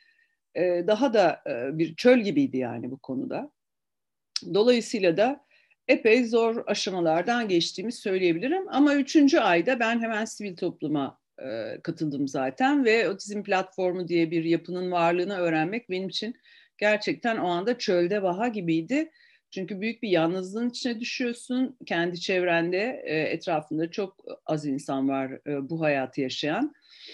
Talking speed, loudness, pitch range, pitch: 125 wpm, -26 LUFS, 165-245 Hz, 195 Hz